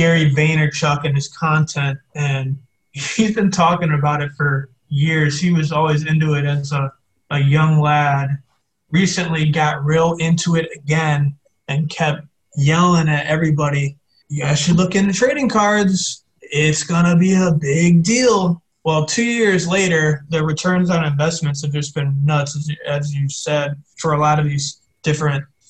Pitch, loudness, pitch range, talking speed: 155 Hz, -17 LUFS, 145-170 Hz, 160 wpm